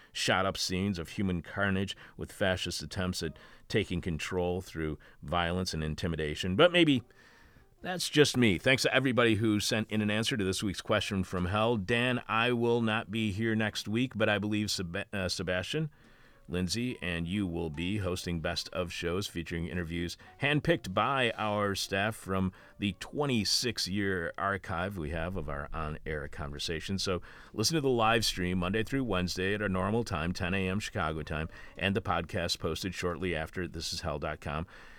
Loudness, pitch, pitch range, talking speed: -31 LUFS, 95 Hz, 85-110 Hz, 175 wpm